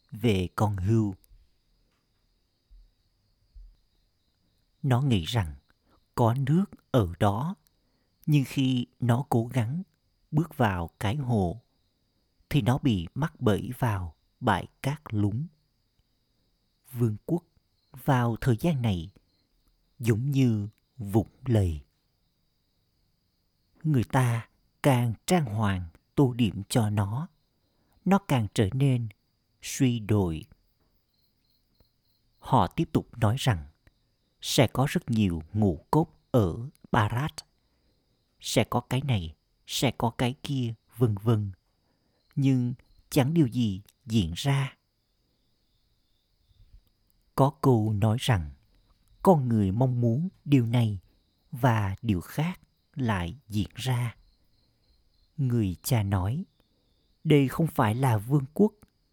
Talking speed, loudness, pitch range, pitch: 110 wpm, -27 LUFS, 100-130 Hz, 115 Hz